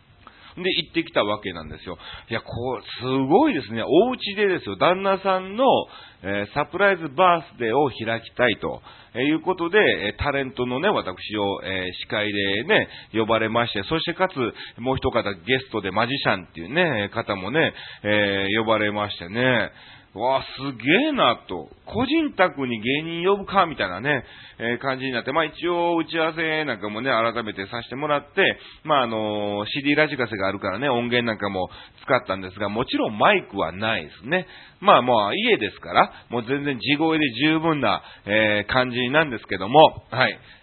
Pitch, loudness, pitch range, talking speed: 125 Hz, -22 LUFS, 105-165 Hz, 355 characters per minute